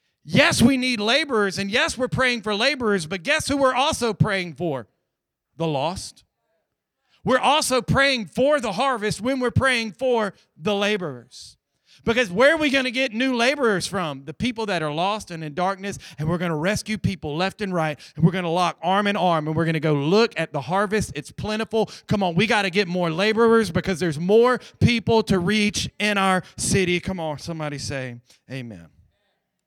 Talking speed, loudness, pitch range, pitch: 200 wpm, -22 LUFS, 165-235 Hz, 200 Hz